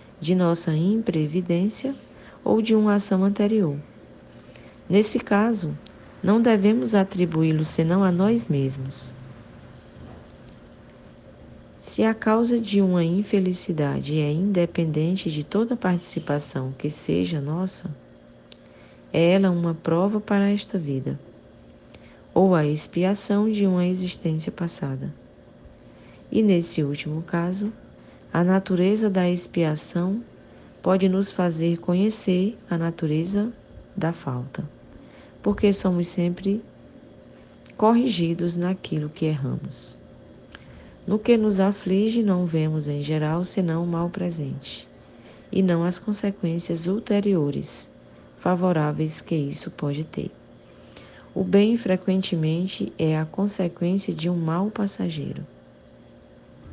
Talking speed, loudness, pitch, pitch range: 105 wpm, -24 LUFS, 175 Hz, 150-195 Hz